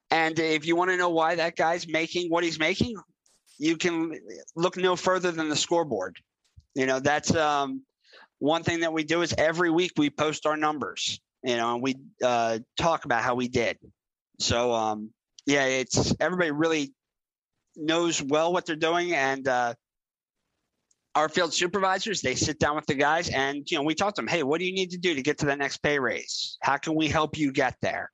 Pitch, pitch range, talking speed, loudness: 155 Hz, 135-170 Hz, 205 wpm, -26 LUFS